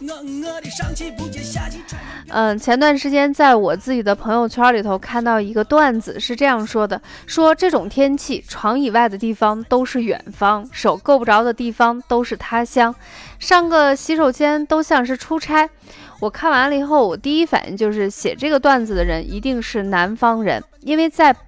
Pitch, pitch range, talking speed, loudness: 250 Hz, 220-295 Hz, 255 characters per minute, -17 LUFS